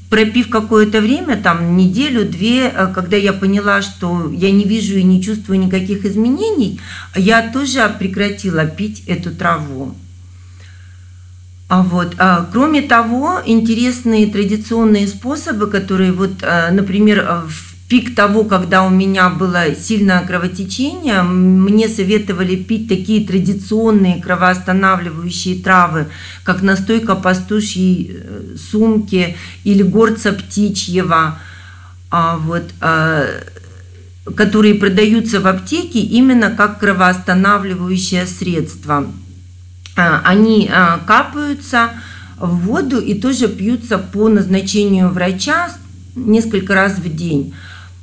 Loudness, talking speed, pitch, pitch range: -14 LUFS, 100 wpm, 190 Hz, 175-215 Hz